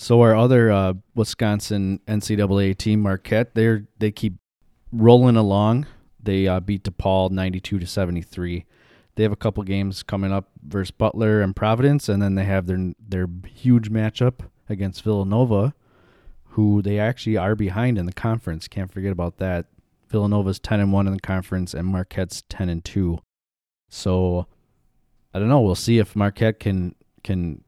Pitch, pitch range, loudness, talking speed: 100 Hz, 95-110 Hz, -21 LUFS, 165 wpm